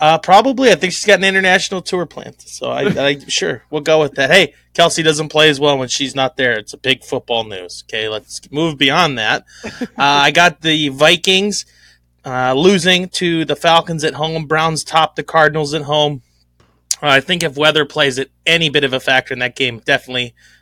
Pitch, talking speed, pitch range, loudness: 155 Hz, 210 wpm, 135-165 Hz, -14 LUFS